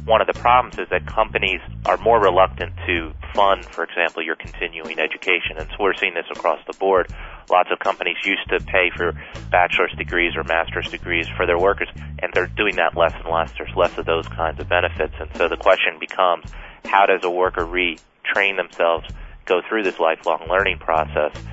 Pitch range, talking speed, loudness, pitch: 80-90 Hz, 200 wpm, -20 LUFS, 85 Hz